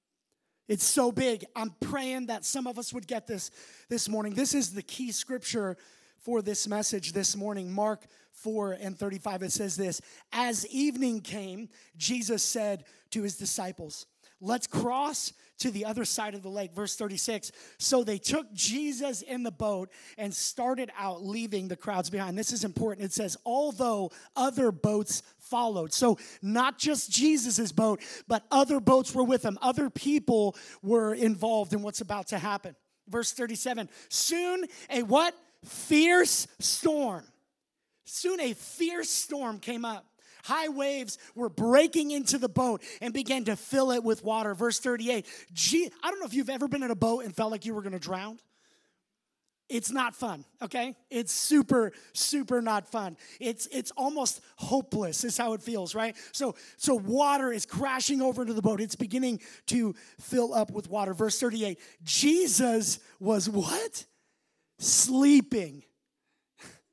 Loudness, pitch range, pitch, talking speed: -29 LUFS, 210-260 Hz, 230 Hz, 160 wpm